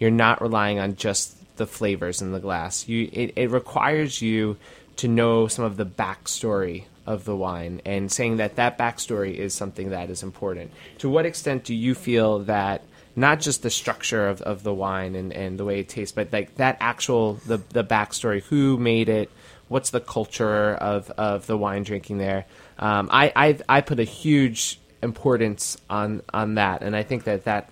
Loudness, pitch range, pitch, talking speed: -24 LUFS, 100-120 Hz, 105 Hz, 195 wpm